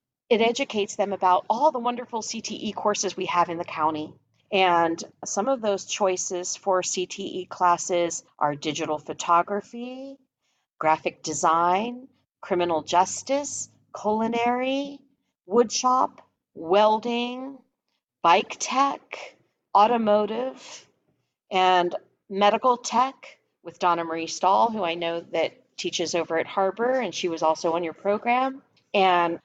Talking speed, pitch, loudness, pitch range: 120 wpm, 195 Hz, -24 LUFS, 170-240 Hz